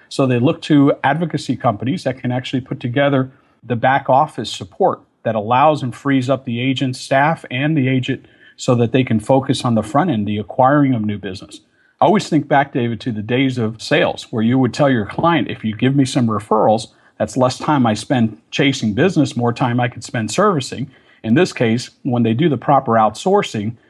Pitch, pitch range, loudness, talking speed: 130 Hz, 115-140 Hz, -17 LUFS, 210 wpm